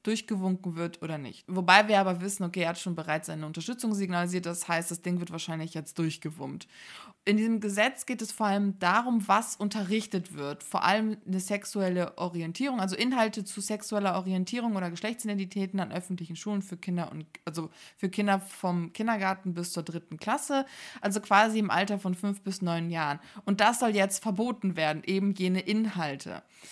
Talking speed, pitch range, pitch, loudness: 180 wpm, 170-210 Hz, 190 Hz, -29 LUFS